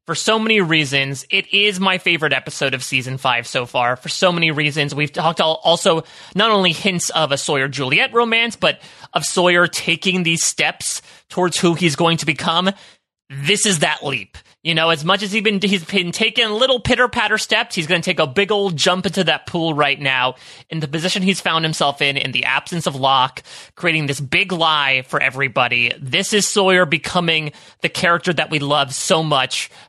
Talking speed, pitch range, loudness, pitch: 200 wpm, 145-190 Hz, -17 LUFS, 170 Hz